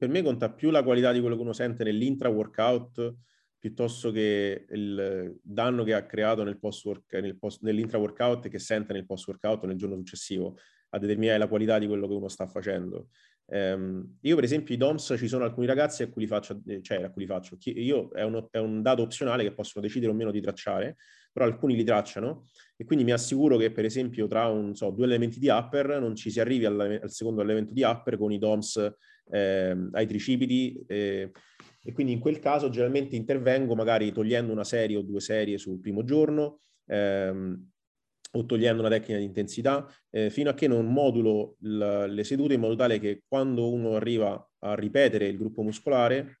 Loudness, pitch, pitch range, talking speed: -28 LUFS, 110 Hz, 105-125 Hz, 205 wpm